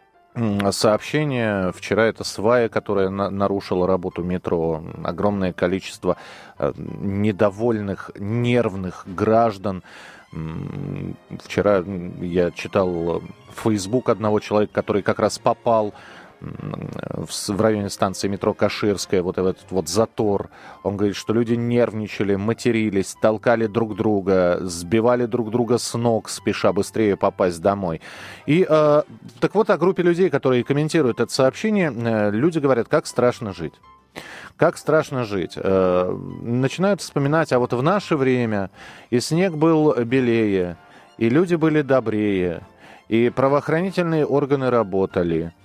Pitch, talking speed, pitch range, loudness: 110 Hz, 120 wpm, 100-130 Hz, -21 LUFS